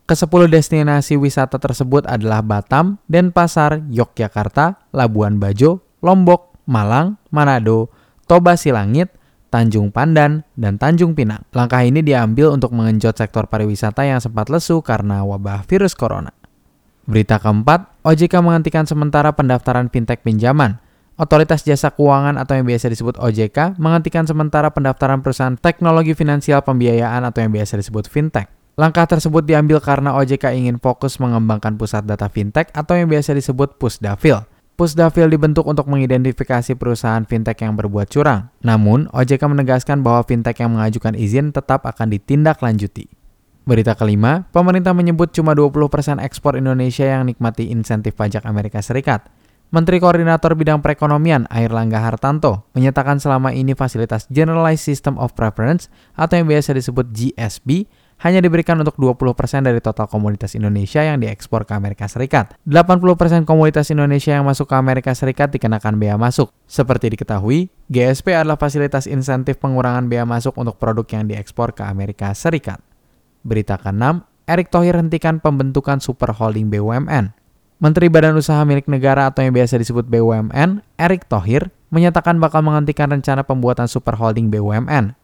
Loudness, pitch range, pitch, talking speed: -15 LUFS, 115-155 Hz, 135 Hz, 140 wpm